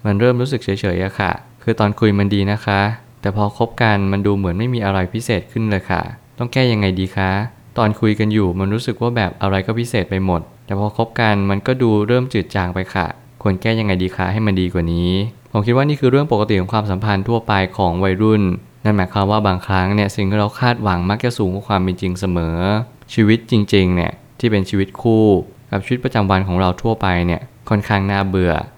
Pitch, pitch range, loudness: 105 Hz, 95-115 Hz, -17 LUFS